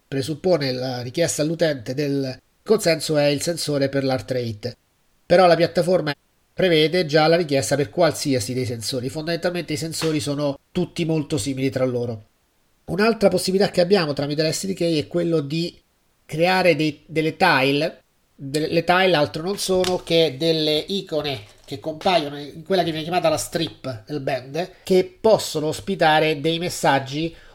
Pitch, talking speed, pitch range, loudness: 155 Hz, 150 wpm, 140-175 Hz, -21 LUFS